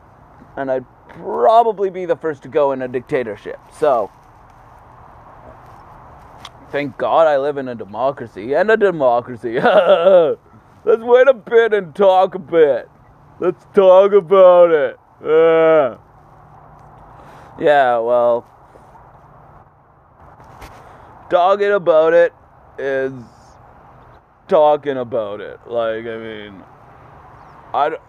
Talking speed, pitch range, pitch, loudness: 105 wpm, 130-200 Hz, 160 Hz, -15 LUFS